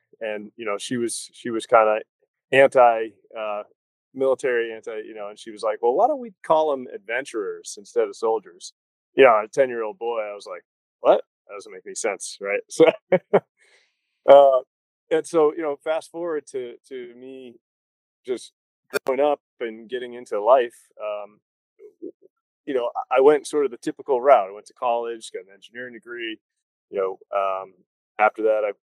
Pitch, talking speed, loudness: 155 Hz, 185 wpm, -22 LUFS